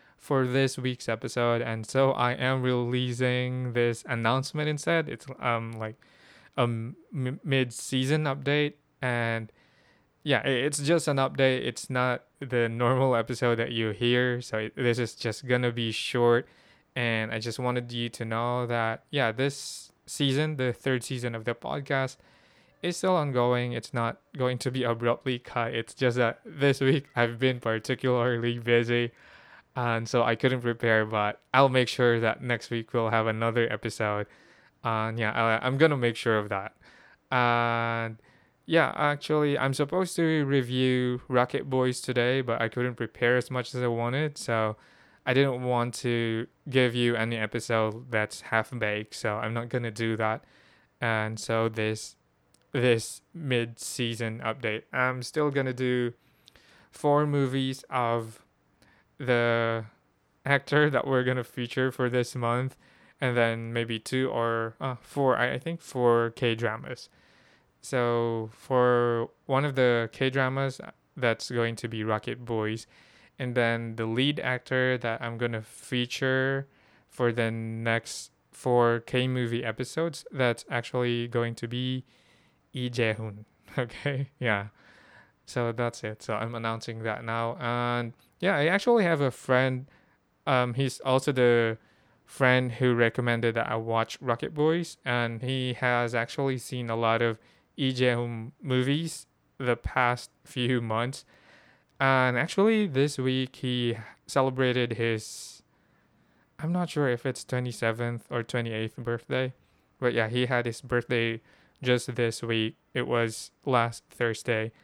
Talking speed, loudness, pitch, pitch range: 150 wpm, -28 LUFS, 120 Hz, 115-130 Hz